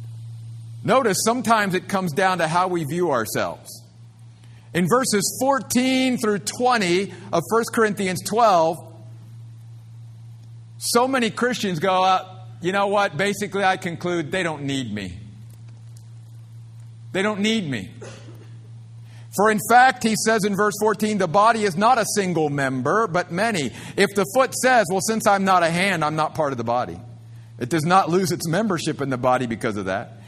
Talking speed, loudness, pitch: 165 wpm, -21 LUFS, 175 Hz